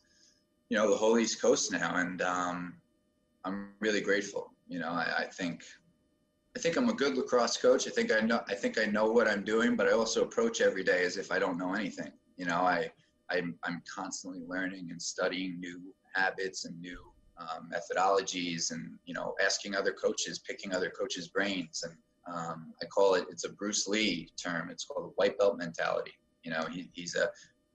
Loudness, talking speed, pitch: -32 LUFS, 200 wpm, 105 Hz